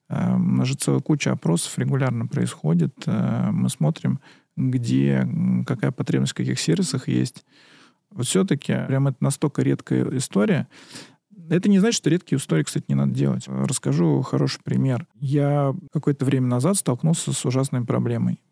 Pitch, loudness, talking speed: 125 Hz, -22 LUFS, 145 wpm